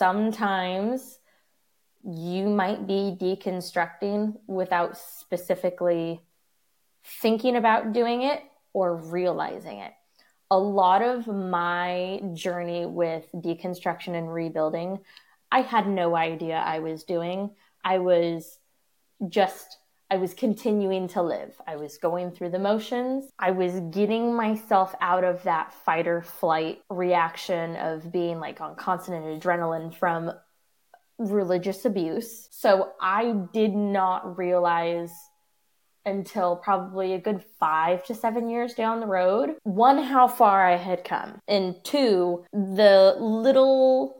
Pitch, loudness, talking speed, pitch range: 185 Hz, -25 LUFS, 120 wpm, 175-215 Hz